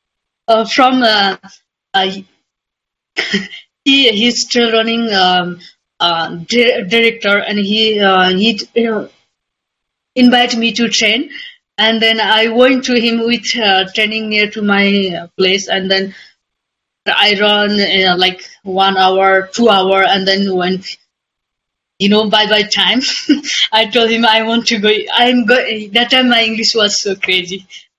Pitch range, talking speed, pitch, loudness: 195-235 Hz, 150 wpm, 215 Hz, -11 LUFS